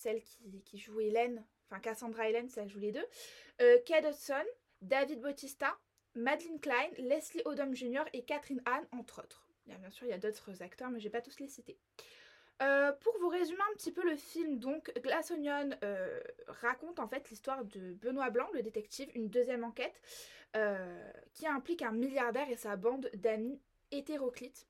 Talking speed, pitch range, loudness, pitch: 195 wpm, 230-300 Hz, -37 LUFS, 260 Hz